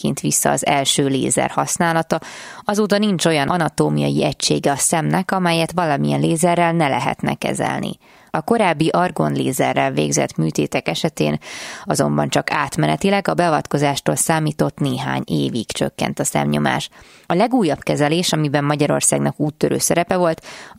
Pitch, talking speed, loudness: 150 Hz, 125 wpm, -18 LUFS